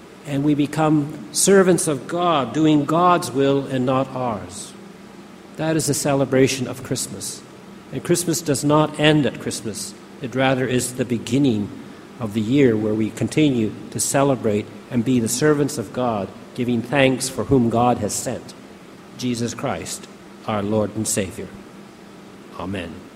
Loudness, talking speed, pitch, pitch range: -20 LUFS, 150 wpm, 130 Hz, 120-150 Hz